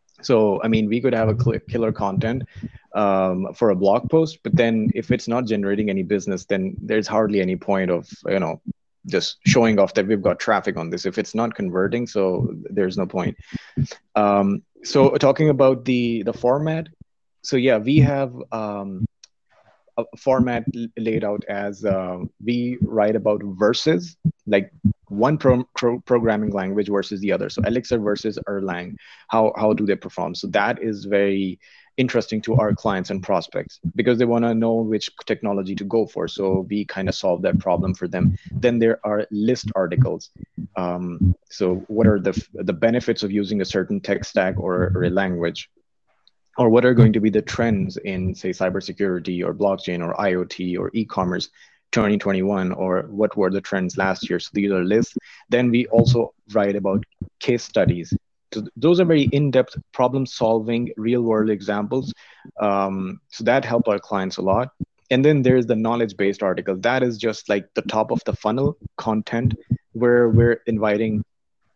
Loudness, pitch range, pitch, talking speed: -21 LUFS, 100-120 Hz, 110 Hz, 175 wpm